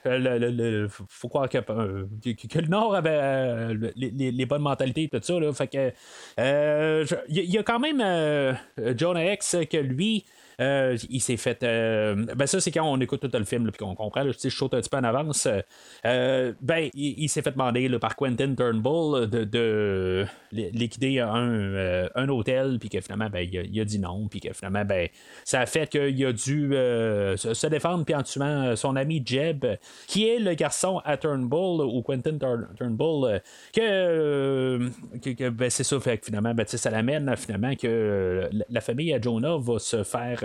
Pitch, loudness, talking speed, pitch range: 130 Hz, -26 LUFS, 205 wpm, 115-150 Hz